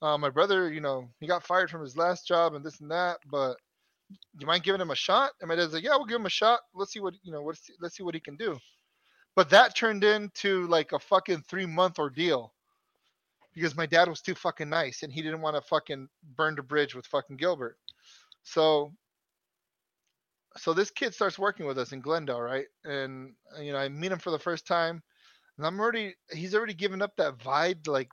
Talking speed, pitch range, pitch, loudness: 225 wpm, 150-190 Hz, 170 Hz, -28 LUFS